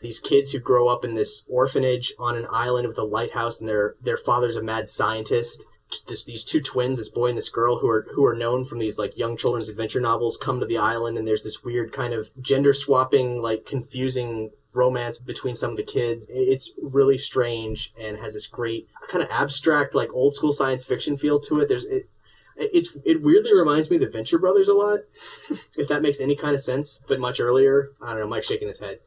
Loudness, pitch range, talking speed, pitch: -23 LUFS, 115-150 Hz, 225 wpm, 130 Hz